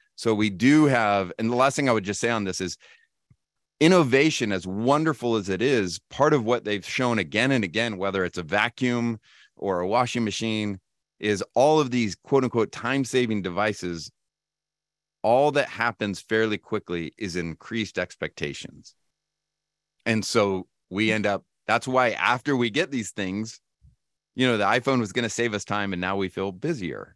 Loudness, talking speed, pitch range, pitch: -24 LUFS, 180 wpm, 100-130 Hz, 110 Hz